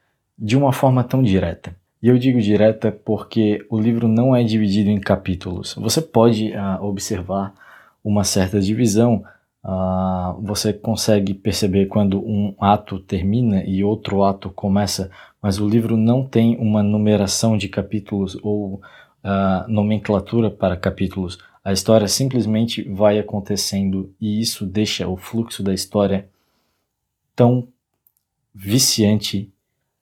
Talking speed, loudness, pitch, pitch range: 130 wpm, -19 LUFS, 105 Hz, 100-115 Hz